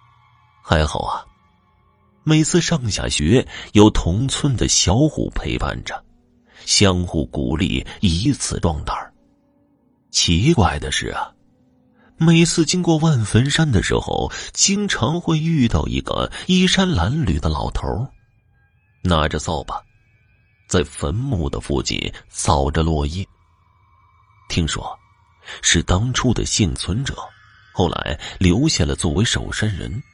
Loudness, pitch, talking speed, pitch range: -19 LUFS, 105 Hz, 175 characters per minute, 90-125 Hz